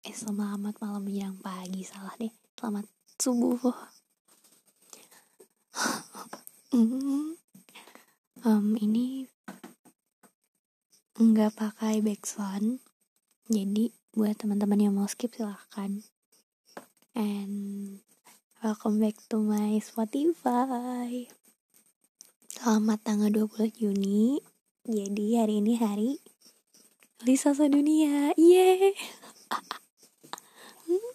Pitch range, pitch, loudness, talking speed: 210-245 Hz, 220 Hz, -28 LUFS, 75 wpm